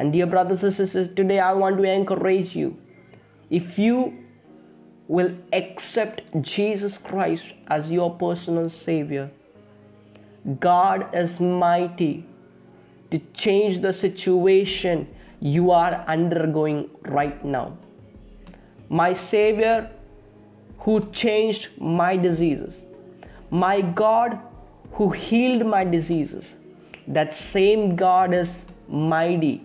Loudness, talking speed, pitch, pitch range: -22 LUFS, 100 wpm, 180 Hz, 155-195 Hz